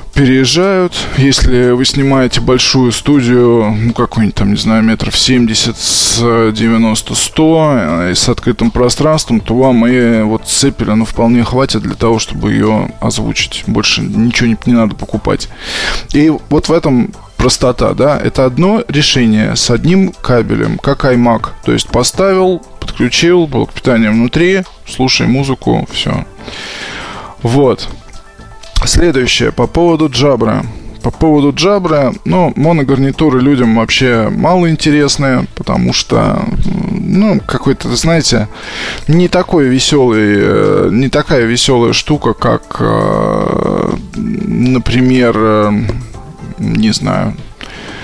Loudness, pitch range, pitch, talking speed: -11 LUFS, 115-155 Hz, 130 Hz, 115 wpm